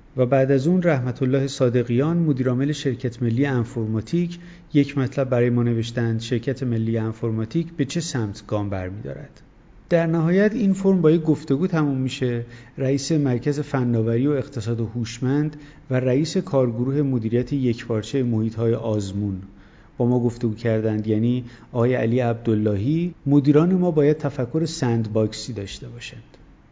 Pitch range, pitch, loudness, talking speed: 115-145 Hz, 125 Hz, -22 LUFS, 140 wpm